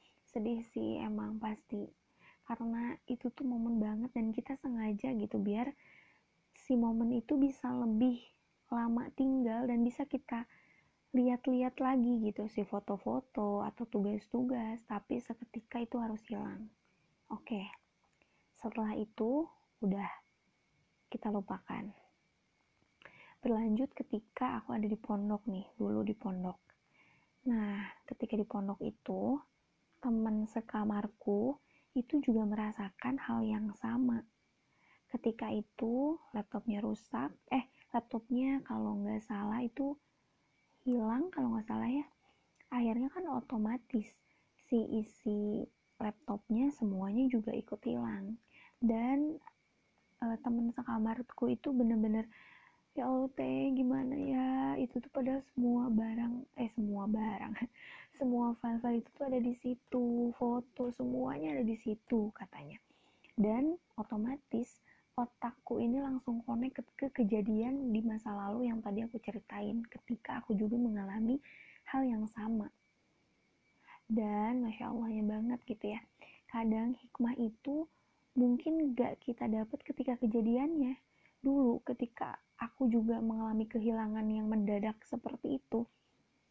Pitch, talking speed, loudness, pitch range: 235 Hz, 115 wpm, -37 LUFS, 220-255 Hz